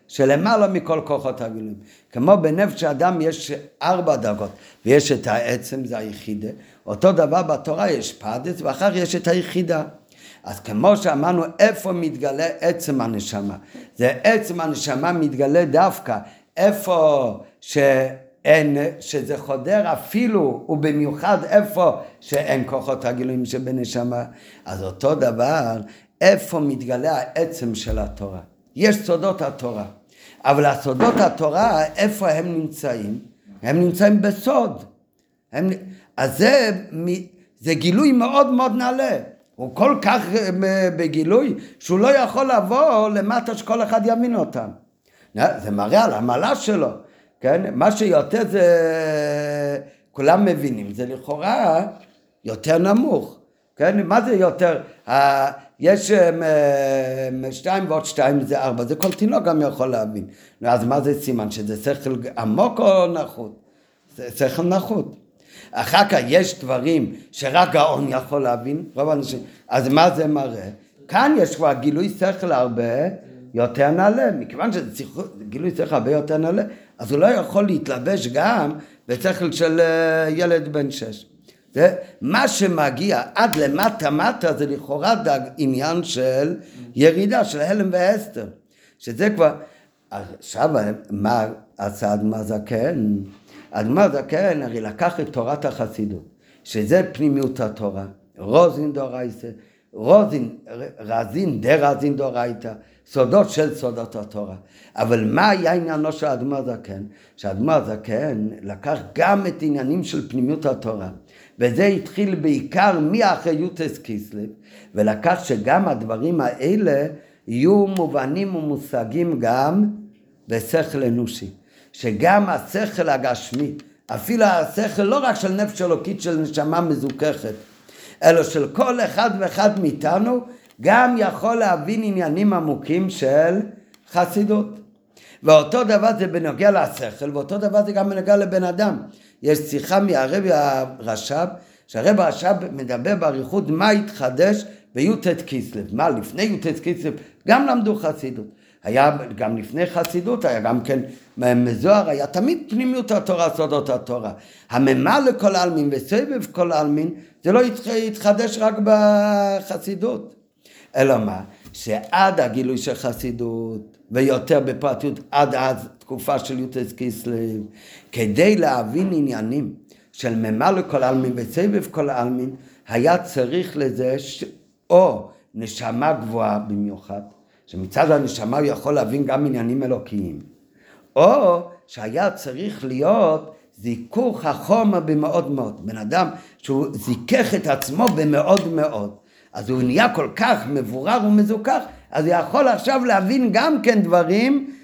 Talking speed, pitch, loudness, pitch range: 125 wpm, 150 Hz, -19 LUFS, 125-190 Hz